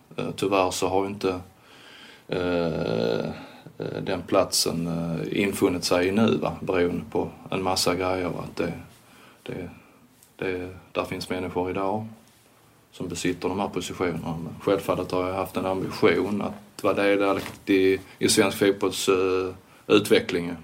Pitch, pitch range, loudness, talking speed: 90 Hz, 90-95 Hz, -25 LUFS, 140 wpm